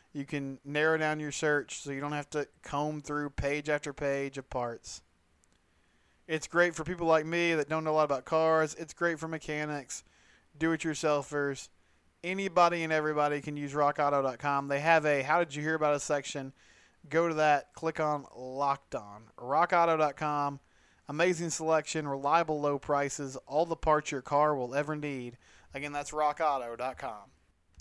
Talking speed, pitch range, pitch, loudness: 165 wpm, 140-160 Hz, 145 Hz, -31 LUFS